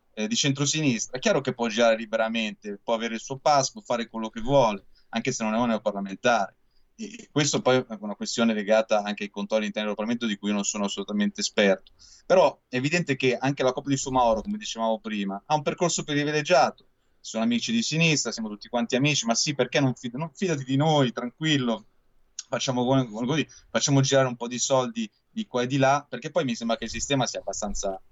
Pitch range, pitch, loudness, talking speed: 110-140 Hz, 120 Hz, -25 LUFS, 210 wpm